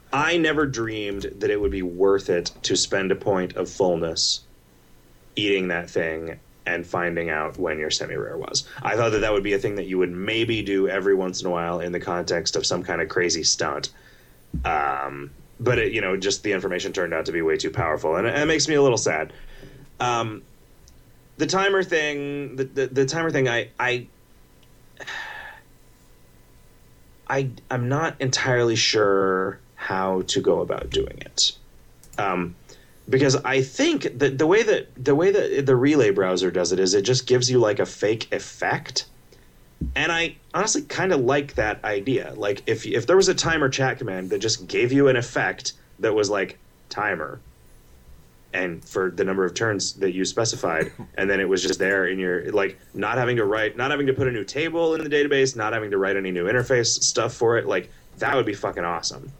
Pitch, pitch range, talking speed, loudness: 125 Hz, 95-150 Hz, 200 wpm, -23 LUFS